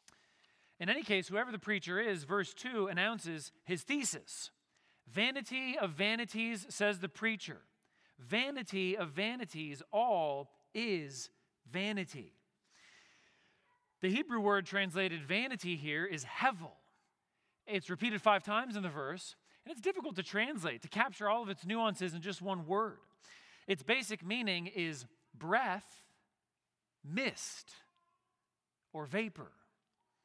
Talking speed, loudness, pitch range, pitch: 125 wpm, -37 LUFS, 180-225 Hz, 200 Hz